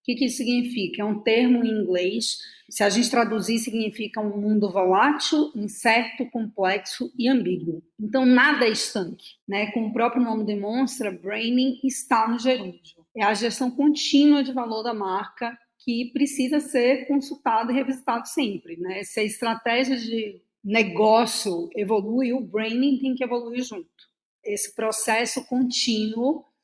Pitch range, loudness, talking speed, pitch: 210-255 Hz, -23 LUFS, 150 wpm, 235 Hz